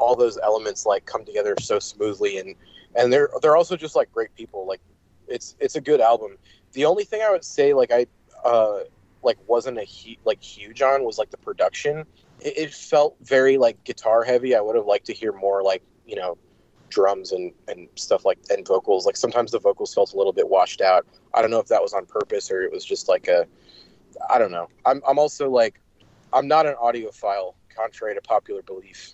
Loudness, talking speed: -22 LUFS, 220 wpm